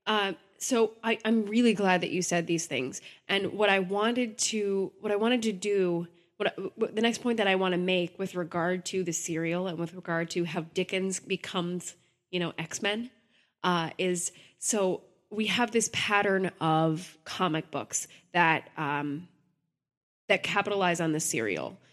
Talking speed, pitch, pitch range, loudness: 180 wpm, 185 Hz, 170-205 Hz, -29 LUFS